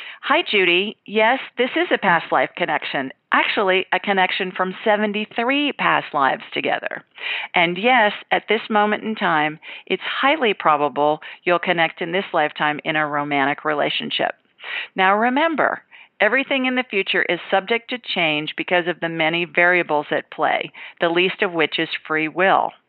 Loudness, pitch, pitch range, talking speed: -19 LUFS, 185 Hz, 160-215 Hz, 155 wpm